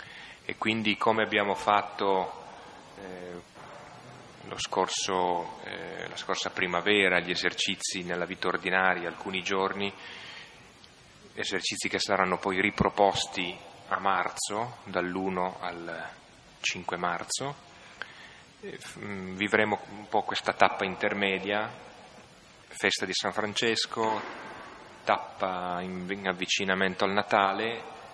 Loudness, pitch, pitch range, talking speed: -29 LUFS, 95 Hz, 90-105 Hz, 95 wpm